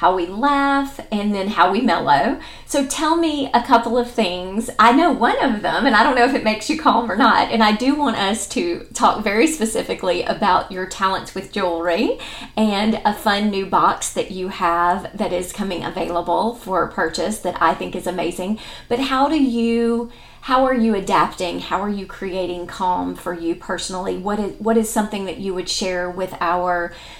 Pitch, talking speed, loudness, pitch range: 200 Hz, 200 wpm, -19 LUFS, 180-235 Hz